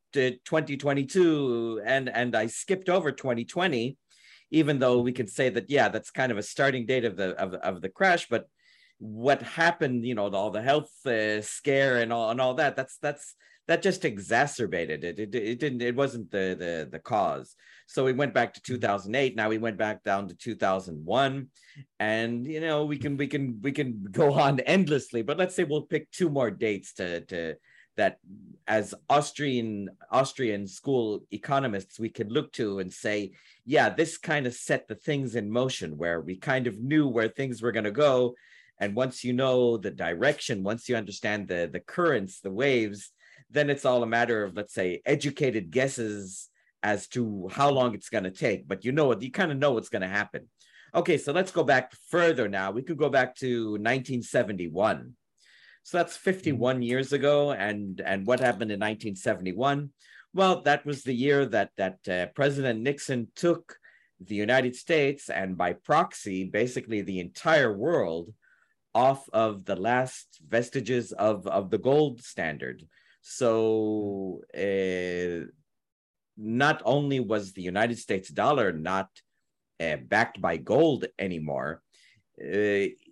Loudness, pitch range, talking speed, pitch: -28 LUFS, 105-140 Hz, 175 wpm, 125 Hz